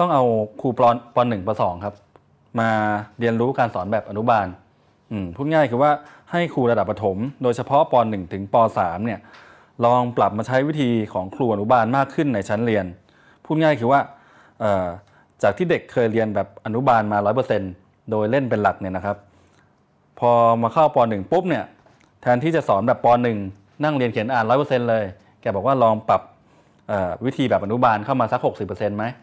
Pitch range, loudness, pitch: 105-130 Hz, -20 LUFS, 115 Hz